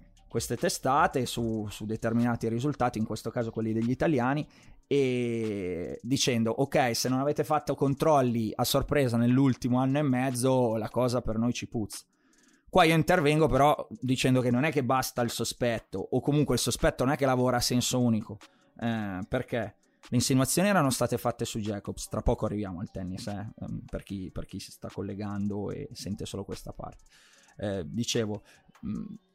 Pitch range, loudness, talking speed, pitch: 110-135 Hz, -28 LUFS, 170 wpm, 120 Hz